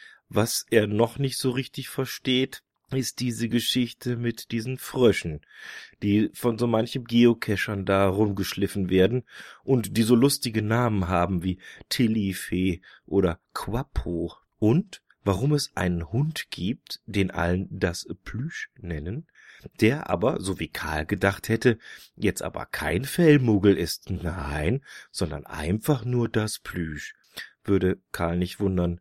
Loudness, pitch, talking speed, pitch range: -26 LUFS, 105 Hz, 130 wpm, 90-125 Hz